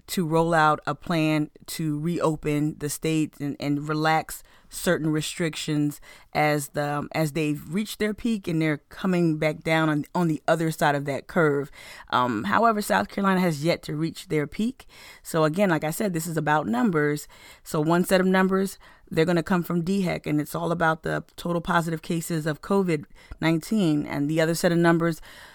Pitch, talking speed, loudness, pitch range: 160 Hz, 190 wpm, -25 LUFS, 150-175 Hz